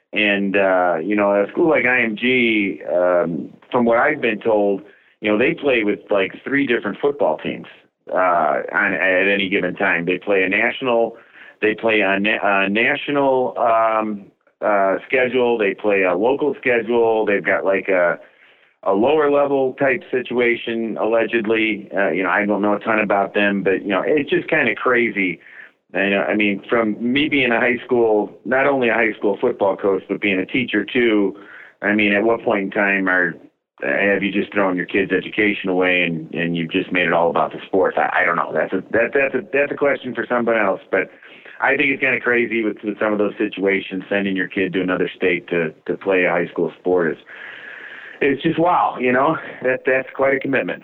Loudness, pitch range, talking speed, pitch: -18 LUFS, 95-120 Hz, 205 wpm, 105 Hz